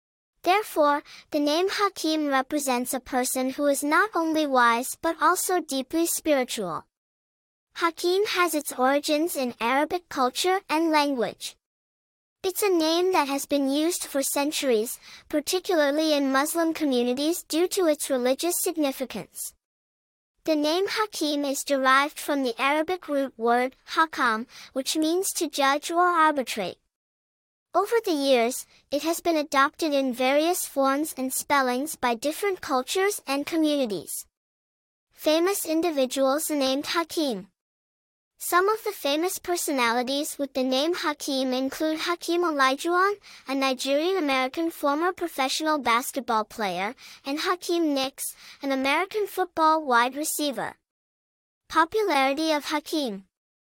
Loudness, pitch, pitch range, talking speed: -25 LUFS, 295 Hz, 265-335 Hz, 125 wpm